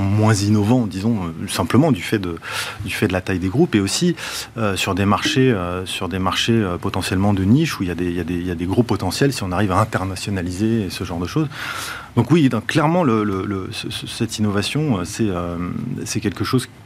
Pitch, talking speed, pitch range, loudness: 105 Hz, 220 wpm, 95-120 Hz, -20 LUFS